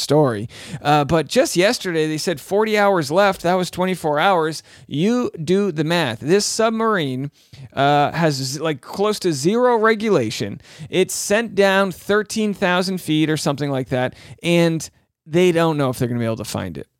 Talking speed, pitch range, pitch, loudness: 175 wpm, 140-195 Hz, 165 Hz, -19 LUFS